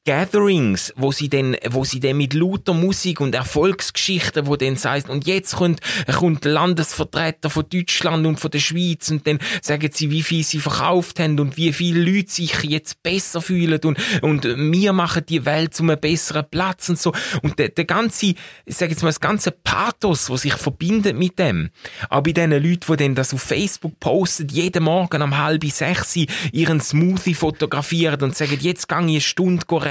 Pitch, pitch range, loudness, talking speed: 160 Hz, 150-175 Hz, -19 LUFS, 185 wpm